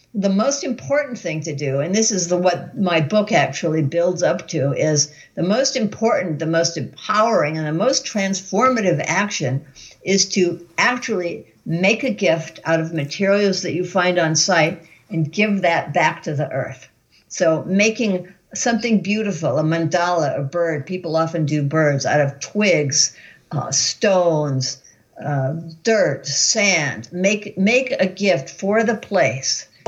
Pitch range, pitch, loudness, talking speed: 155-205 Hz, 175 Hz, -19 LUFS, 155 wpm